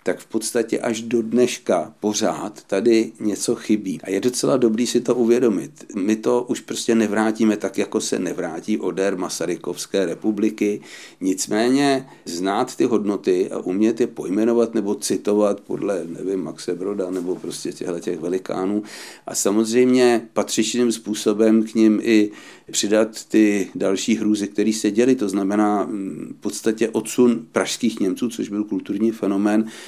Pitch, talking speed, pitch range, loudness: 110 Hz, 145 wpm, 105-120 Hz, -21 LUFS